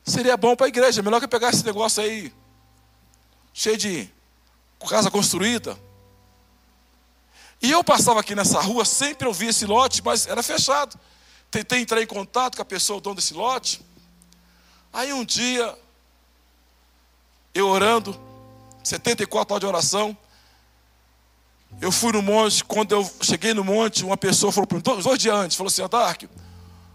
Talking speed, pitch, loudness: 150 wpm, 200 Hz, -21 LUFS